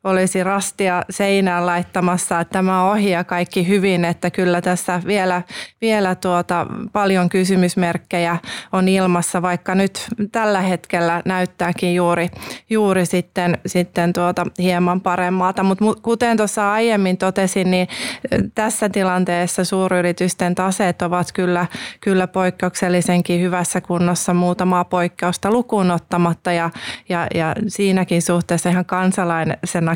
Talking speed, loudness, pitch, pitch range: 115 wpm, -18 LUFS, 180 Hz, 175-190 Hz